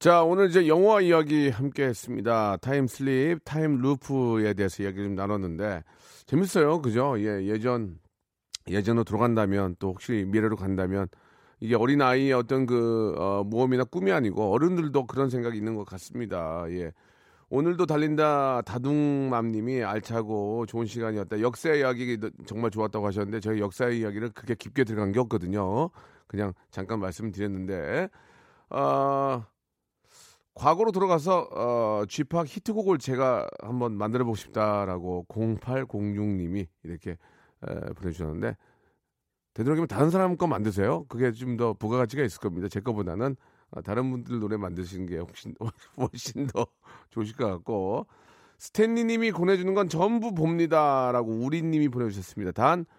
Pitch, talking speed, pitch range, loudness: 115 Hz, 335 characters per minute, 105-140 Hz, -27 LUFS